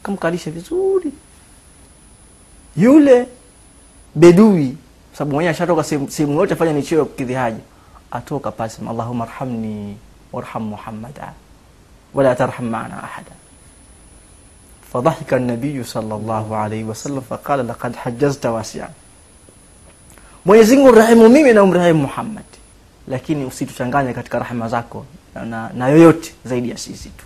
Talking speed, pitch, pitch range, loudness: 105 wpm, 130 Hz, 110-160 Hz, -16 LUFS